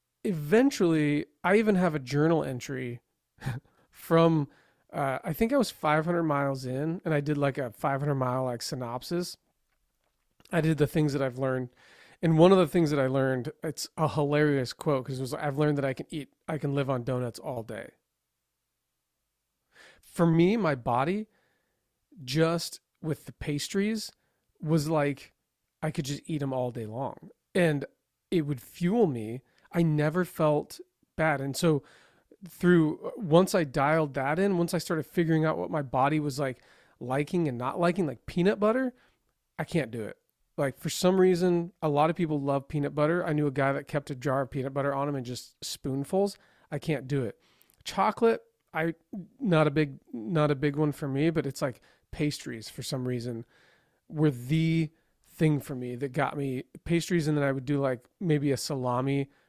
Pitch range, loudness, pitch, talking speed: 135-170 Hz, -28 LUFS, 150 Hz, 185 wpm